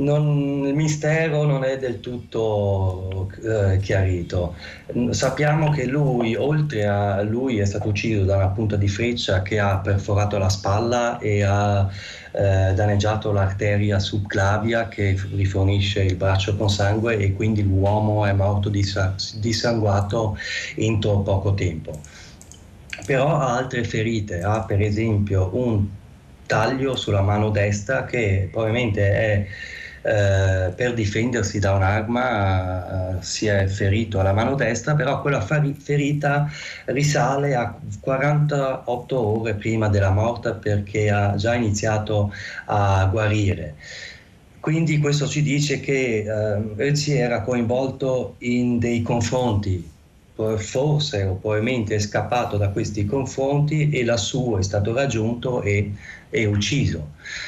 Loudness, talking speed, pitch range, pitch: -22 LUFS, 125 wpm, 100-125 Hz, 105 Hz